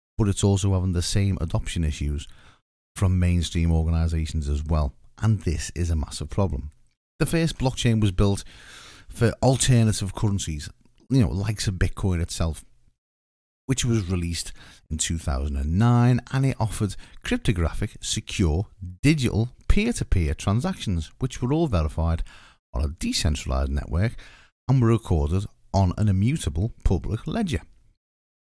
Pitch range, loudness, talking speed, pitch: 80-115 Hz, -25 LUFS, 130 wpm, 95 Hz